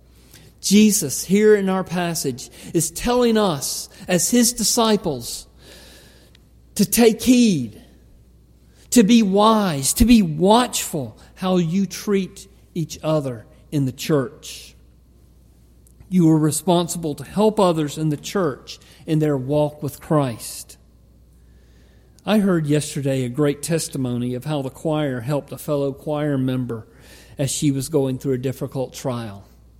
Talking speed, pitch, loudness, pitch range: 130 wpm, 145 Hz, -20 LUFS, 120-180 Hz